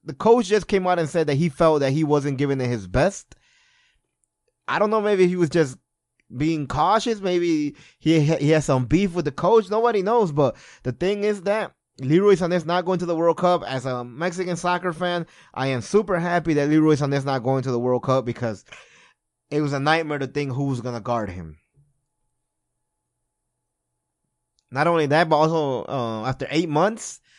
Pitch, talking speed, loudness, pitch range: 155 Hz, 200 wpm, -22 LUFS, 130-180 Hz